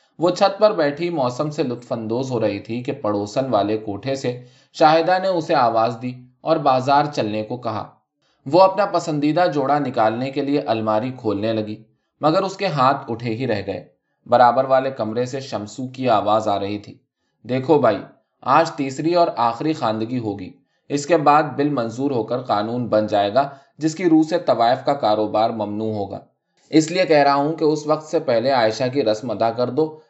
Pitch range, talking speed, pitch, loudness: 110-150 Hz, 195 wpm, 130 Hz, -20 LUFS